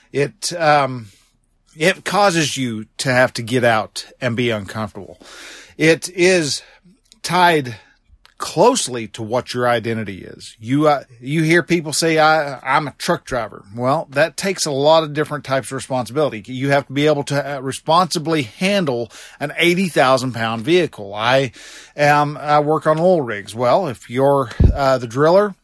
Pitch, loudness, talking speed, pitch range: 140 Hz, -17 LUFS, 160 wpm, 120-160 Hz